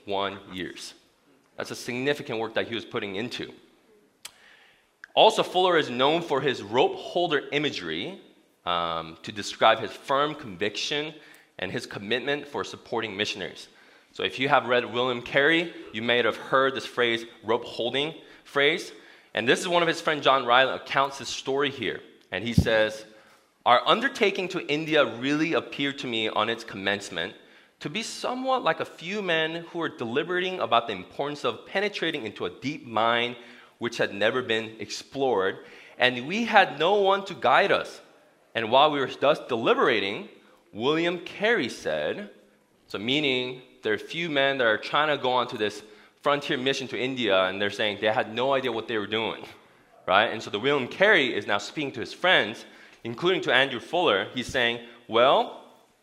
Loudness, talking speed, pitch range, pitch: -25 LUFS, 175 wpm, 110-155 Hz, 130 Hz